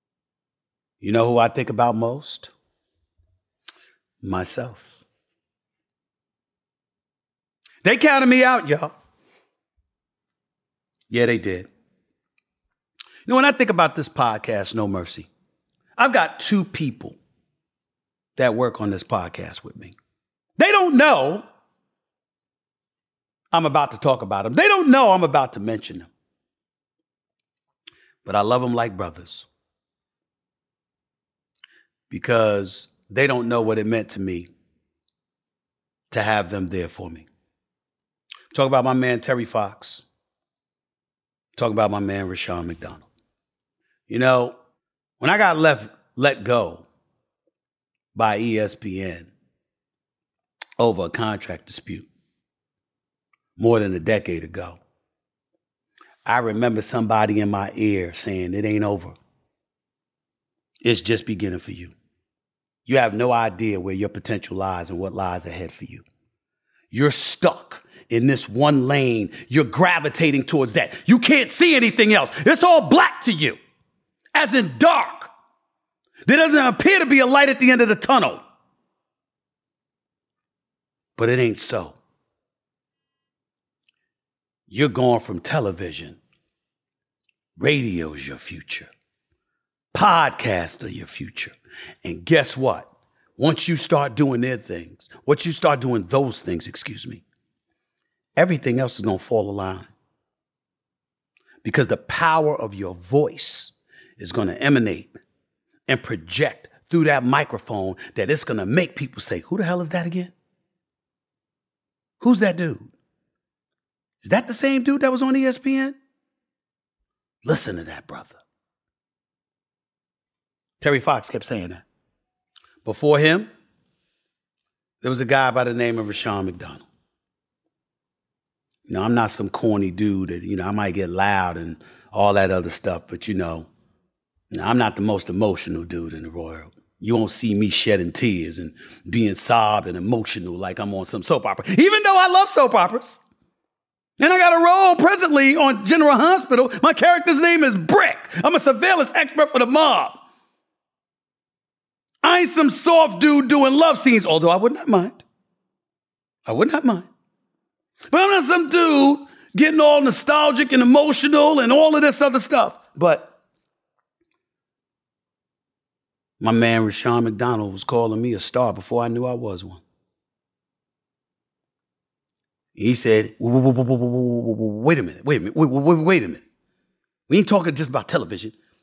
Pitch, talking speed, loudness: 125 Hz, 140 wpm, -19 LUFS